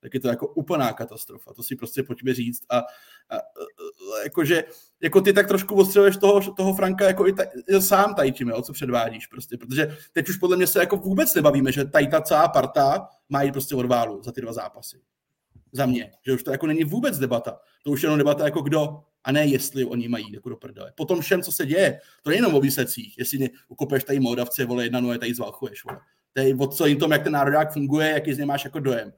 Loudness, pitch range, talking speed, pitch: -22 LUFS, 130-180 Hz, 230 wpm, 140 Hz